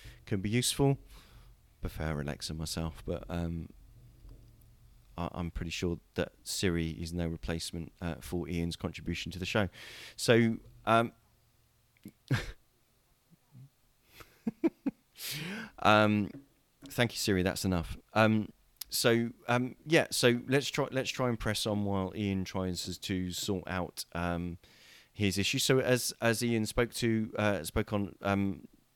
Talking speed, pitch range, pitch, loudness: 135 wpm, 85-120 Hz, 105 Hz, -32 LUFS